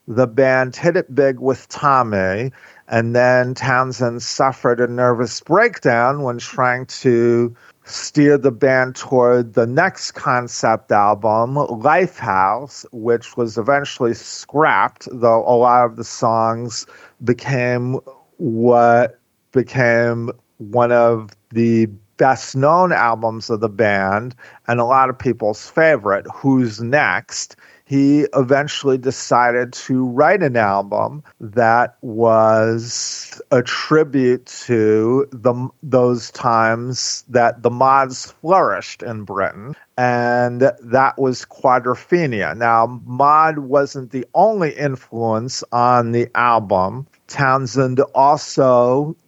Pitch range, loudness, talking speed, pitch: 115-135 Hz, -16 LUFS, 110 wpm, 125 Hz